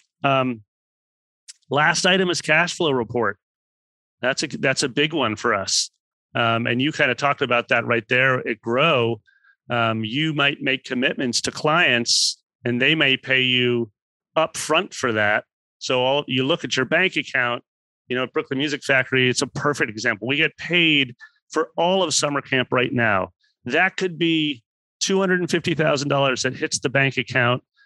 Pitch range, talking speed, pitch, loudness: 120-155 Hz, 170 wpm, 135 Hz, -20 LUFS